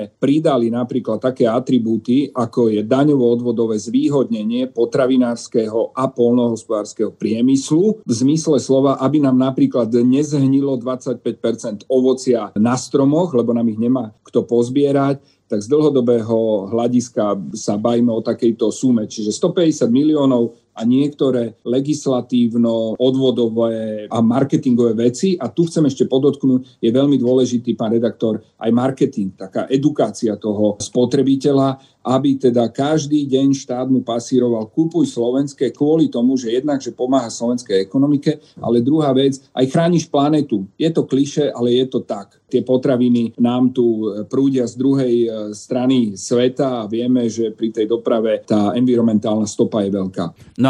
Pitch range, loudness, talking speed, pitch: 115-135 Hz, -17 LUFS, 135 wpm, 125 Hz